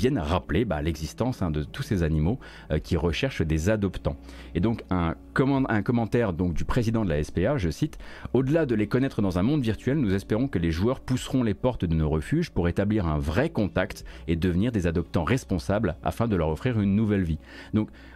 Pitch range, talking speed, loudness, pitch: 80-120 Hz, 215 wpm, -26 LUFS, 95 Hz